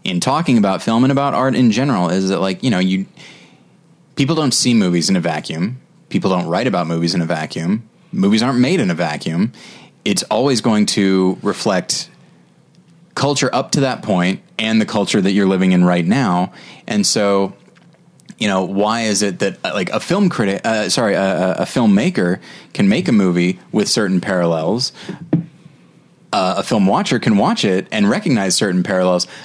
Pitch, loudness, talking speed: 110 Hz, -16 LUFS, 195 wpm